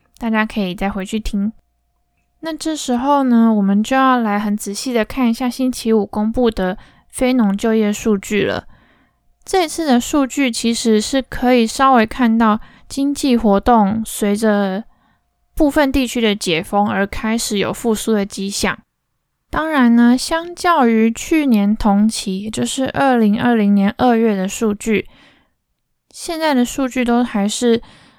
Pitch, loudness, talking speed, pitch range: 230 Hz, -16 LUFS, 225 characters per minute, 210-255 Hz